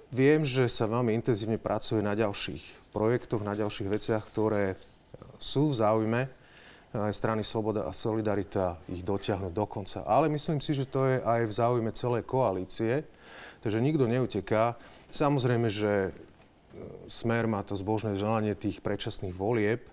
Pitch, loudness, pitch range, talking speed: 110 Hz, -29 LUFS, 105-120 Hz, 145 wpm